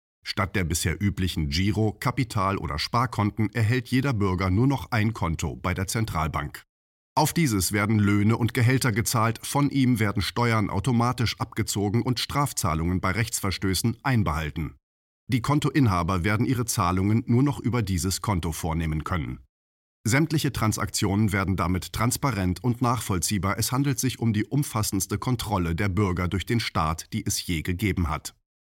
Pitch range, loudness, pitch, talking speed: 90-120 Hz, -25 LUFS, 105 Hz, 150 wpm